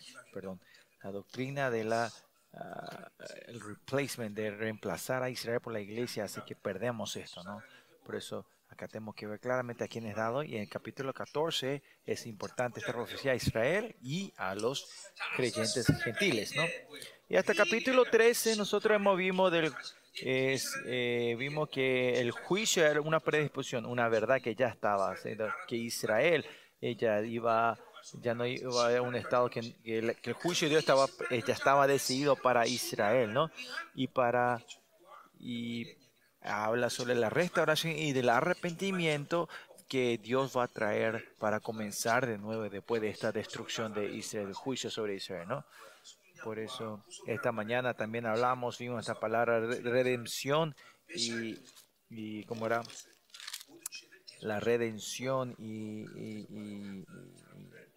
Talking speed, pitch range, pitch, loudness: 150 wpm, 110-135 Hz, 120 Hz, -33 LUFS